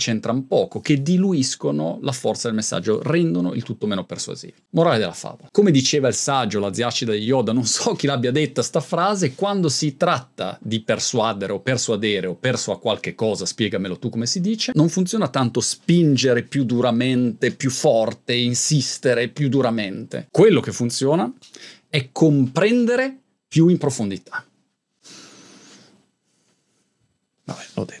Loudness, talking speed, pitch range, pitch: -20 LUFS, 150 wpm, 115-160 Hz, 130 Hz